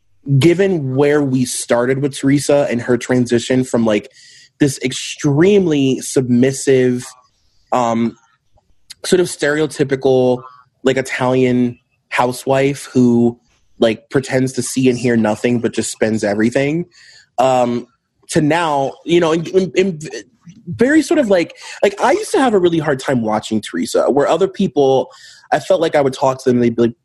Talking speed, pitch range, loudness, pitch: 160 wpm, 120-150 Hz, -15 LUFS, 130 Hz